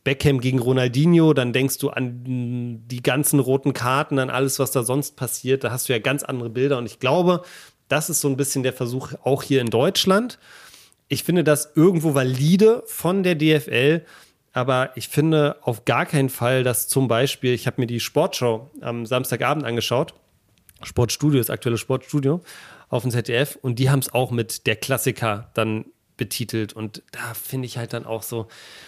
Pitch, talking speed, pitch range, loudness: 130 Hz, 185 wpm, 120-145 Hz, -21 LUFS